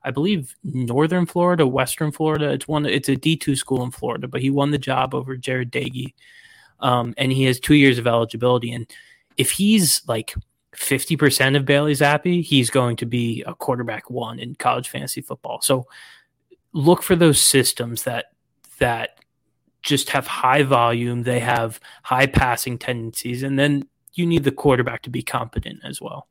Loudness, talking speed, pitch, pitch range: -20 LUFS, 180 wpm, 135 Hz, 125-150 Hz